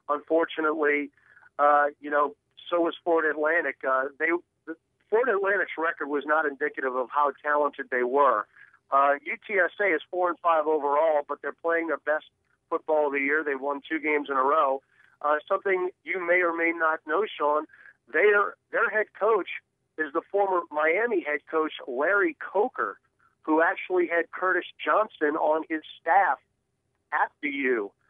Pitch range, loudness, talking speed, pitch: 145-170 Hz, -26 LUFS, 165 wpm, 155 Hz